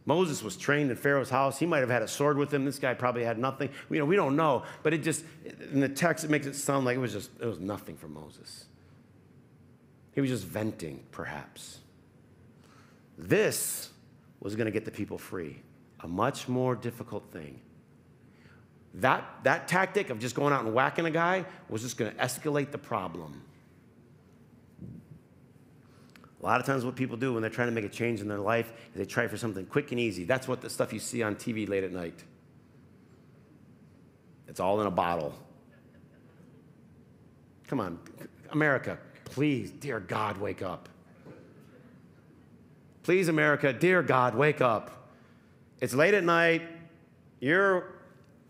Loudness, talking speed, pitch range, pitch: -29 LUFS, 170 wpm, 110-150 Hz, 130 Hz